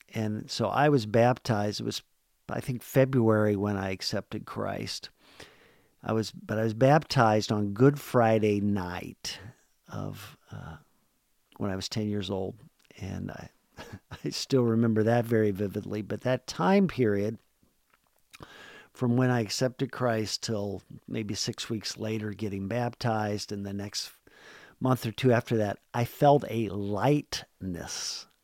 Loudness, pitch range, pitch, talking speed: -28 LUFS, 105-125 Hz, 110 Hz, 145 wpm